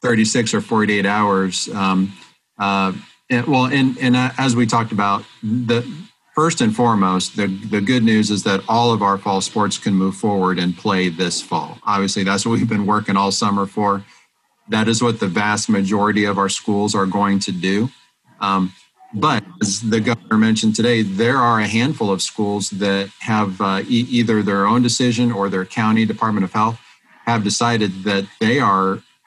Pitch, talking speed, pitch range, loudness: 105 Hz, 185 wpm, 100-115 Hz, -18 LUFS